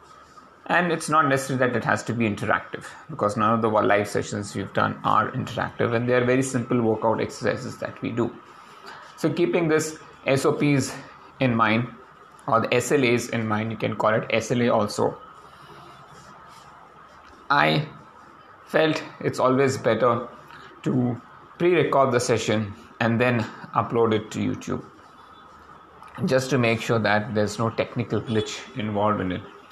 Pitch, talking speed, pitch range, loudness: 120 Hz, 150 wpm, 110-135 Hz, -23 LUFS